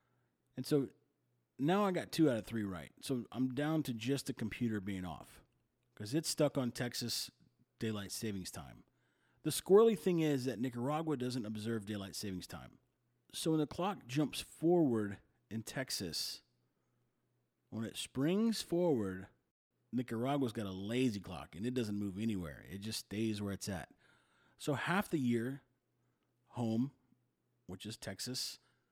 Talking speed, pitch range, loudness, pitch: 155 wpm, 105-135 Hz, -37 LUFS, 120 Hz